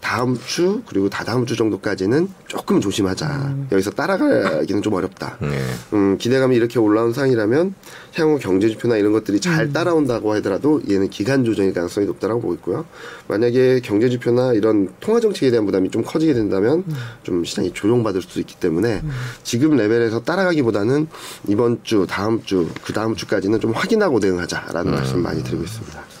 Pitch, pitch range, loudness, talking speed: 120 Hz, 100-145 Hz, -19 LUFS, 415 characters per minute